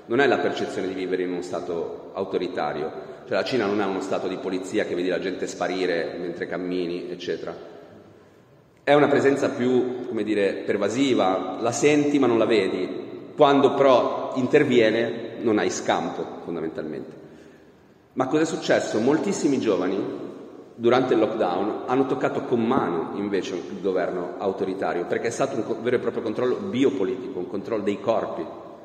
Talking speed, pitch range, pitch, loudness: 160 wpm, 95-145 Hz, 120 Hz, -24 LUFS